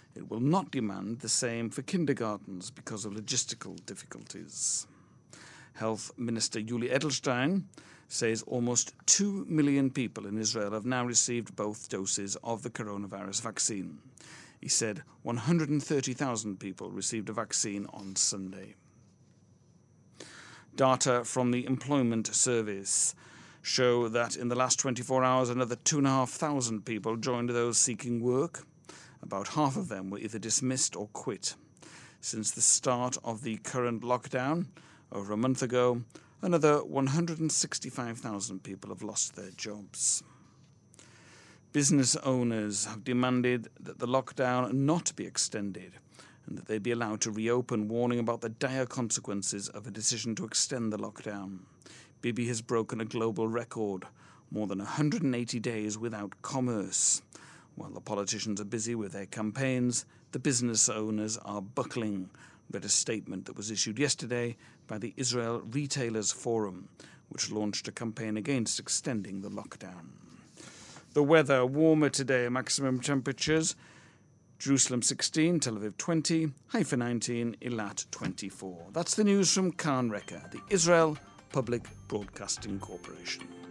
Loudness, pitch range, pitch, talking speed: -31 LUFS, 110-135 Hz, 120 Hz, 140 wpm